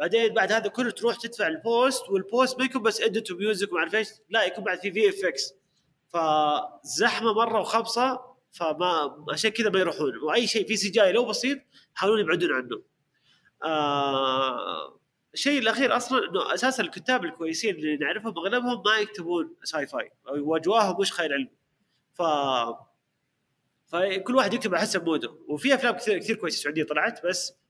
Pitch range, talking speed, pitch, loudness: 170-235 Hz, 160 wpm, 215 Hz, -26 LUFS